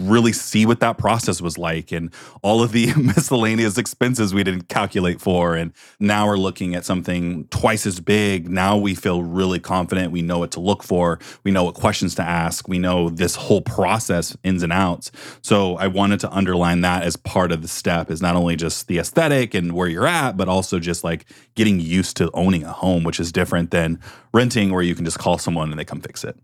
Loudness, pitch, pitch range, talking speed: -20 LUFS, 95 Hz, 85-105 Hz, 220 wpm